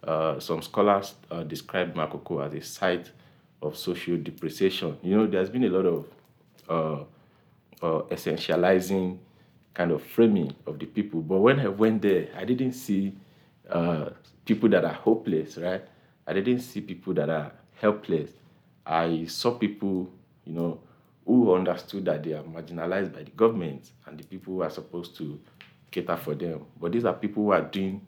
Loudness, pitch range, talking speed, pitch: -27 LUFS, 85-105 Hz, 170 wpm, 95 Hz